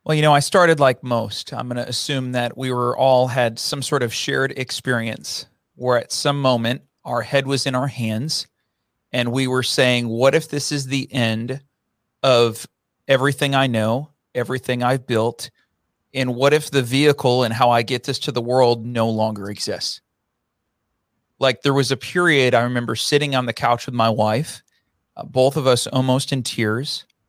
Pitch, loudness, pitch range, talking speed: 125 Hz, -19 LUFS, 120-140 Hz, 185 wpm